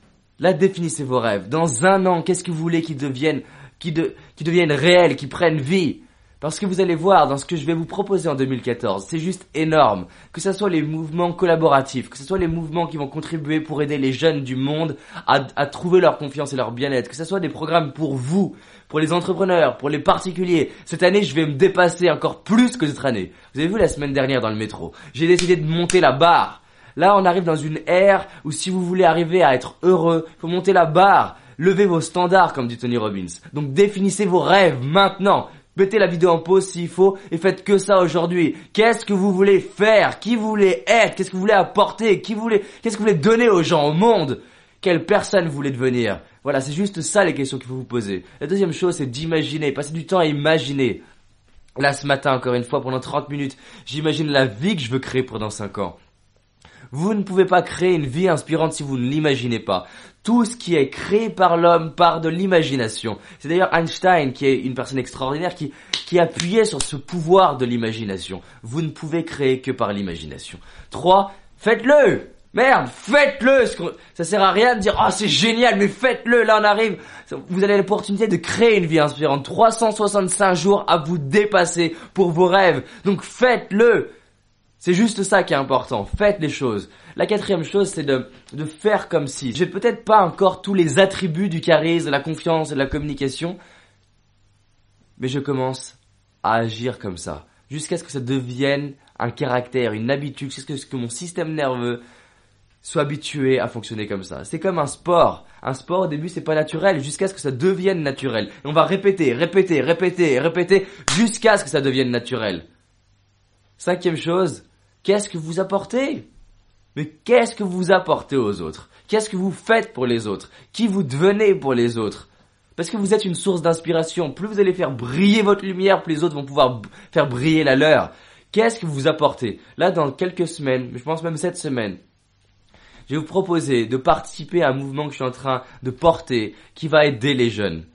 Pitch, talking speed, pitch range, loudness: 160 Hz, 205 wpm, 130-190 Hz, -19 LUFS